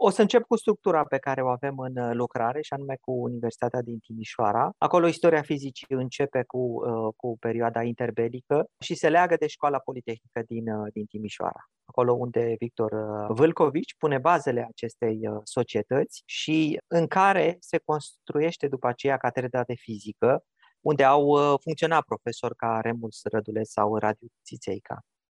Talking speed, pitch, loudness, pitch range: 145 wpm, 125 Hz, -26 LUFS, 115-150 Hz